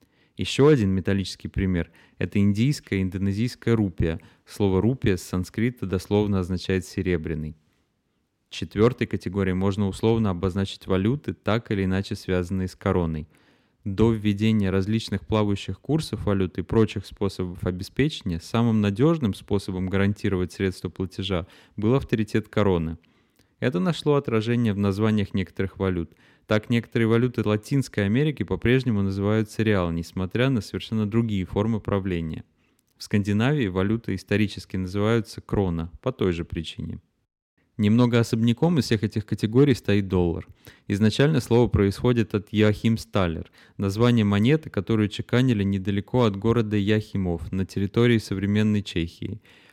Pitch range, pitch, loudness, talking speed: 95-115 Hz, 105 Hz, -24 LUFS, 125 wpm